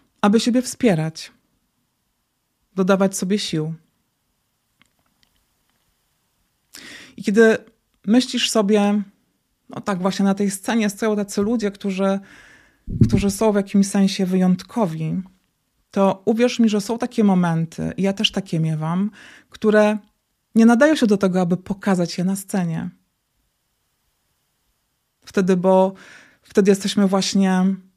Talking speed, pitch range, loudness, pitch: 115 wpm, 190-215 Hz, -19 LUFS, 200 Hz